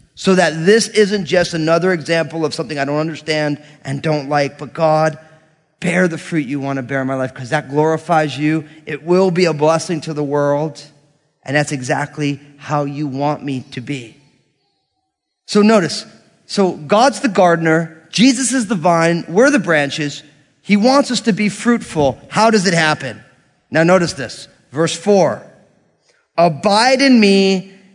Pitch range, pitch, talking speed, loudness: 145-190 Hz, 160 Hz, 170 wpm, -15 LUFS